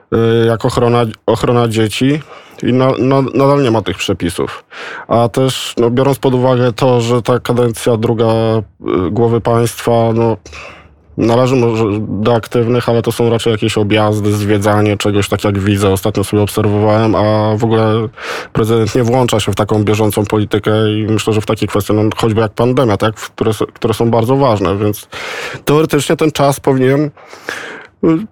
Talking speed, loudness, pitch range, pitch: 165 wpm, -13 LUFS, 105-125 Hz, 115 Hz